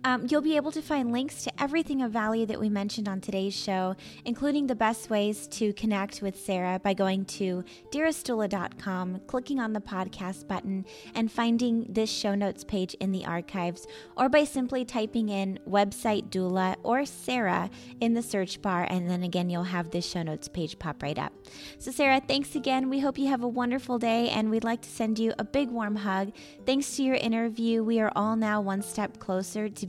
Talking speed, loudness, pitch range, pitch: 205 wpm, -29 LUFS, 190-245 Hz, 215 Hz